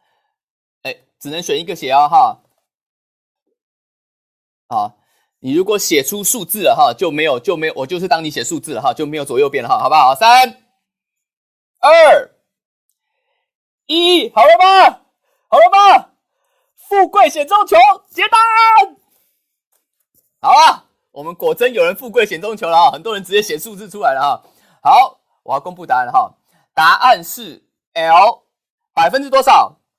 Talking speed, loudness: 210 characters per minute, -12 LUFS